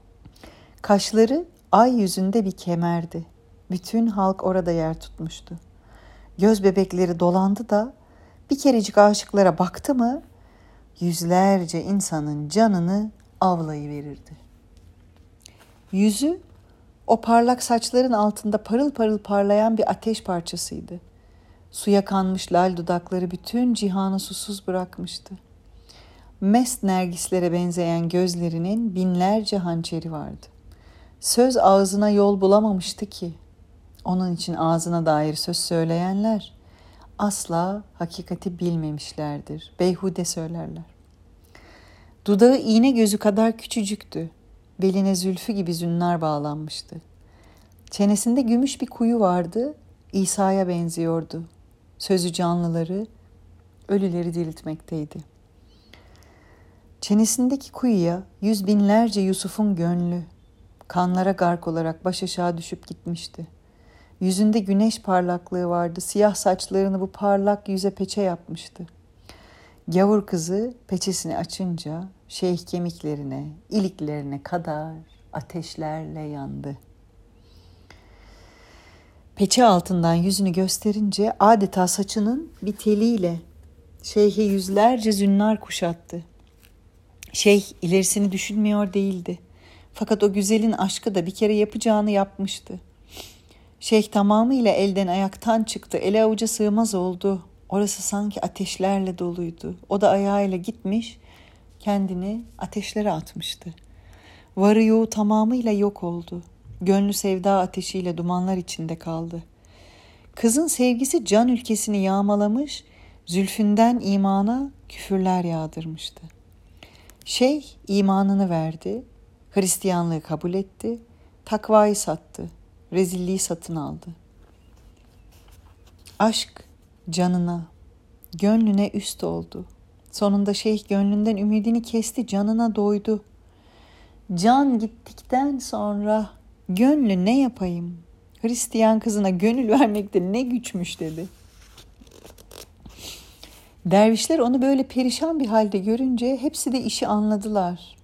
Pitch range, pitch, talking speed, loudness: 160-210 Hz, 185 Hz, 95 wpm, -22 LUFS